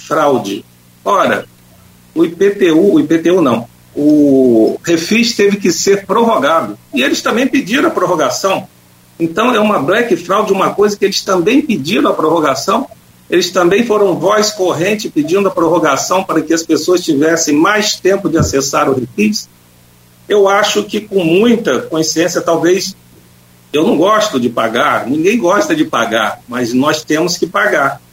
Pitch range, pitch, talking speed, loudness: 145-210 Hz, 180 Hz, 155 wpm, -12 LUFS